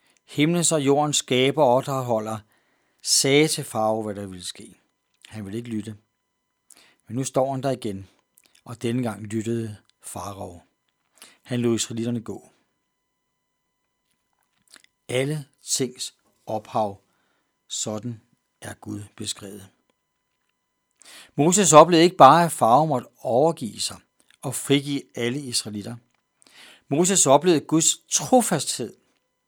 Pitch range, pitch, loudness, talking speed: 110-145 Hz, 120 Hz, -21 LUFS, 115 wpm